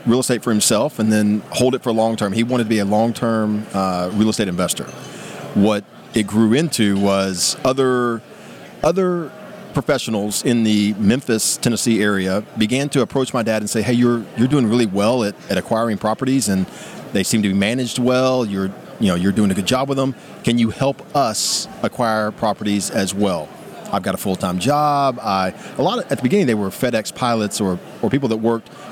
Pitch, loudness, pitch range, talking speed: 115 Hz, -18 LUFS, 105-130 Hz, 205 wpm